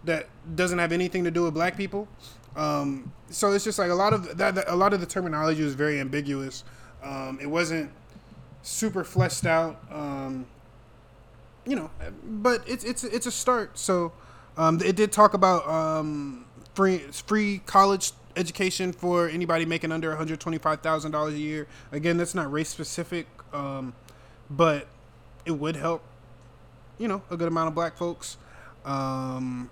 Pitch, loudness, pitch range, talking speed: 160 Hz, -26 LUFS, 140-180 Hz, 170 wpm